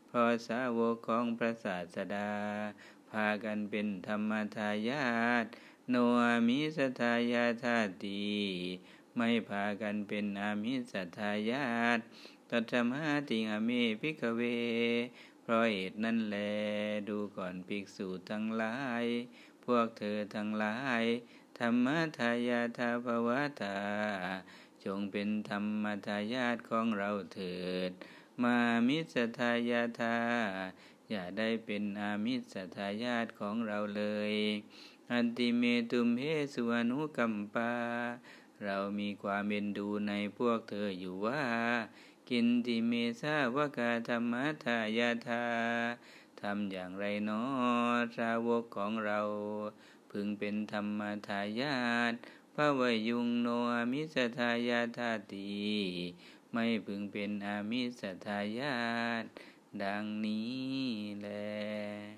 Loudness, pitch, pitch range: -35 LUFS, 115 Hz, 105-120 Hz